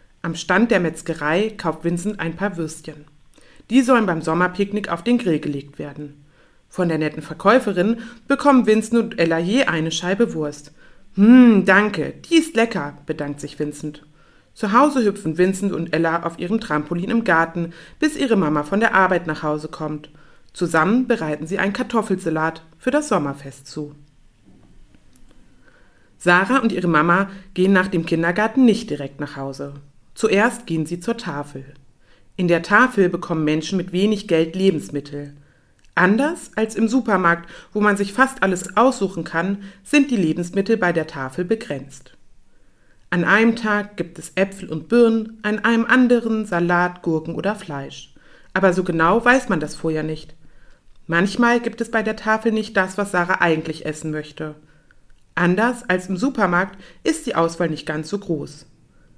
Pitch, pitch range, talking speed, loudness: 180 Hz, 155-215 Hz, 160 wpm, -19 LUFS